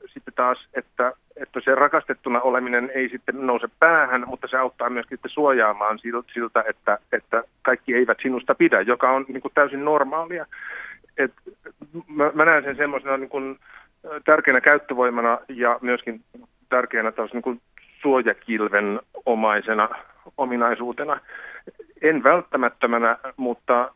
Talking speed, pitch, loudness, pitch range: 130 wpm, 130 Hz, -21 LUFS, 120-145 Hz